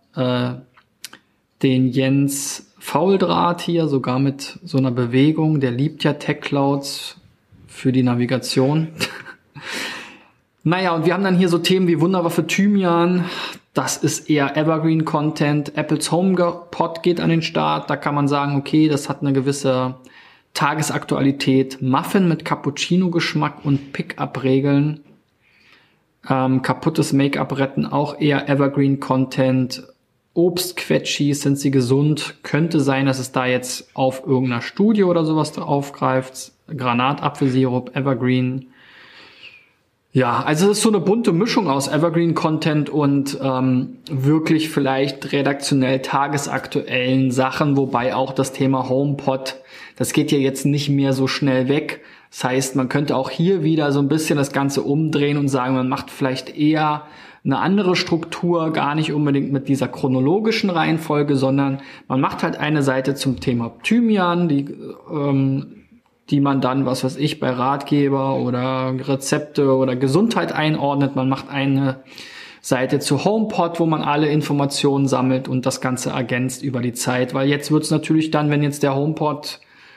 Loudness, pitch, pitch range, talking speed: -19 LUFS, 140 Hz, 130-155 Hz, 145 wpm